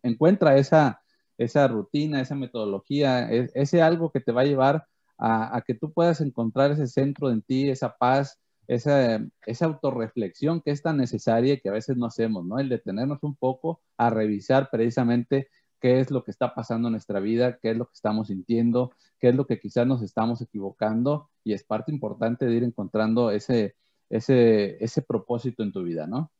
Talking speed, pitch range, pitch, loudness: 190 wpm, 115-140 Hz, 125 Hz, -25 LUFS